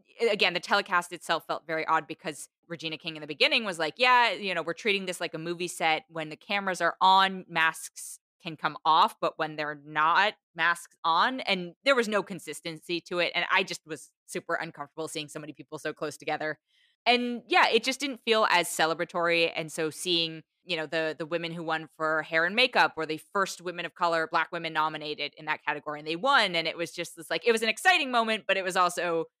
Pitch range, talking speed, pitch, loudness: 160-190 Hz, 230 wpm, 170 Hz, -27 LUFS